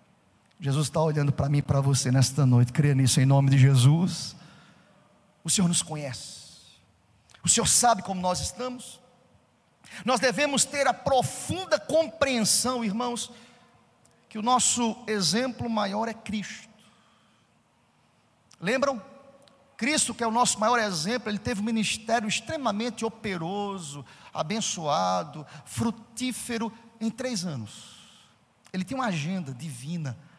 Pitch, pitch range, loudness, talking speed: 205 Hz, 150-240 Hz, -26 LUFS, 125 wpm